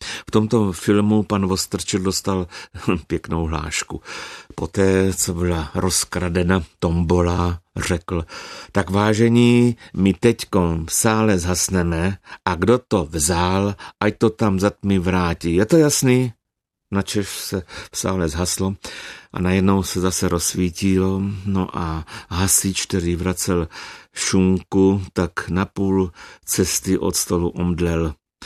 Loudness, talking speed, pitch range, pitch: -20 LUFS, 120 wpm, 85-100 Hz, 95 Hz